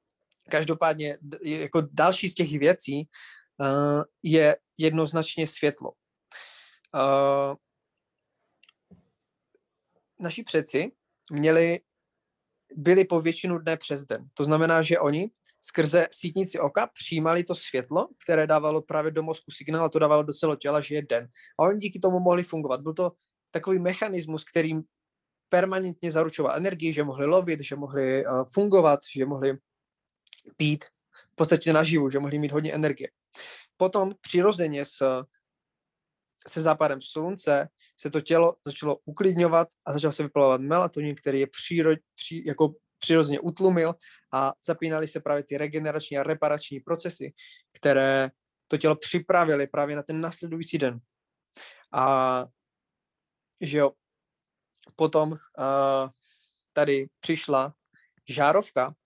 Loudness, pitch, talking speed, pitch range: -26 LUFS, 155 Hz, 125 wpm, 140-170 Hz